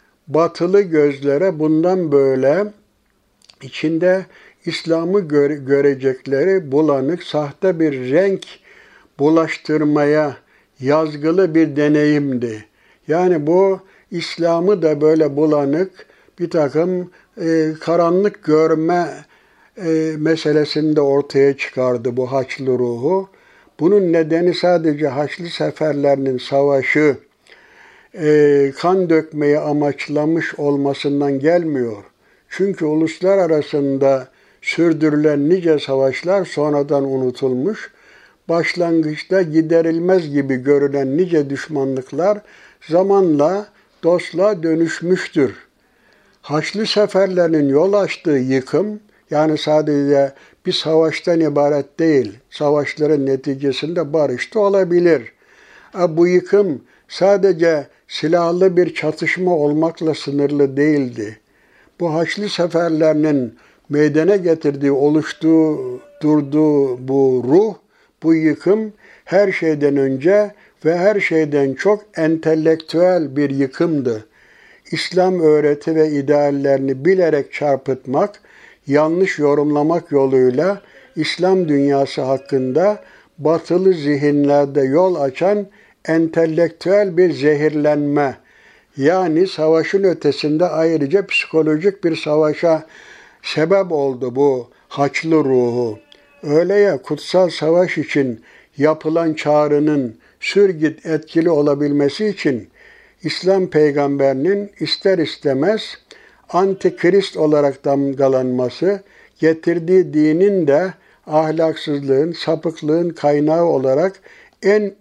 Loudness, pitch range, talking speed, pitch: -16 LUFS, 145-180 Hz, 85 wpm, 155 Hz